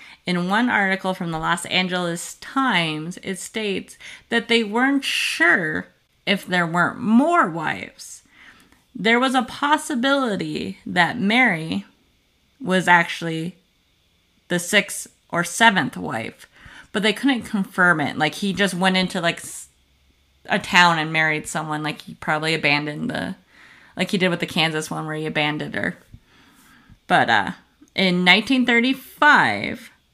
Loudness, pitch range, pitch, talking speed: -20 LUFS, 160-230 Hz, 185 Hz, 135 wpm